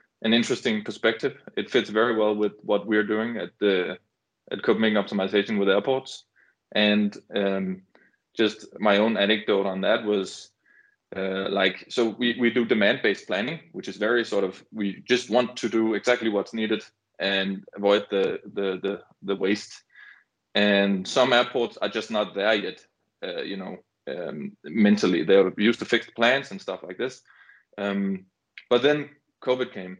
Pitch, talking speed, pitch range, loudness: 105 Hz, 165 wpm, 100-120 Hz, -24 LUFS